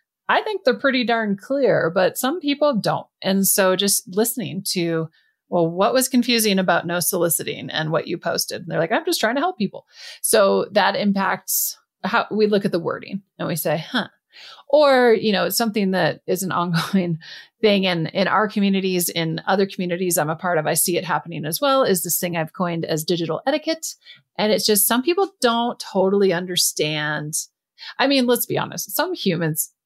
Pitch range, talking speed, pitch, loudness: 170-230 Hz, 200 wpm, 190 Hz, -20 LUFS